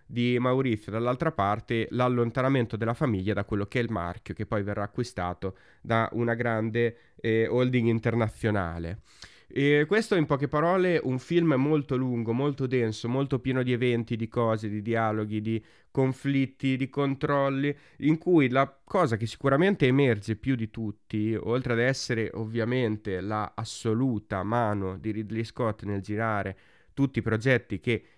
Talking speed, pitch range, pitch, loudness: 155 wpm, 110-135 Hz, 115 Hz, -27 LUFS